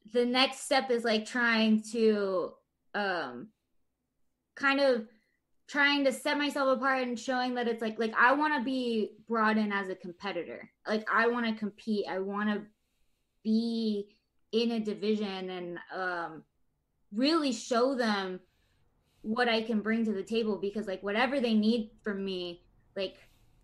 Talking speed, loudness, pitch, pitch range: 155 wpm, -30 LUFS, 220 Hz, 200-245 Hz